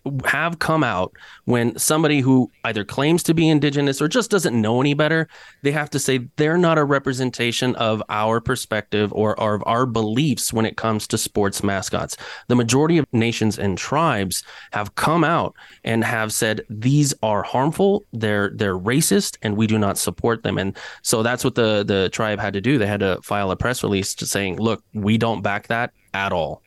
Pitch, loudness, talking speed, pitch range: 115 Hz, -20 LUFS, 200 wpm, 105-140 Hz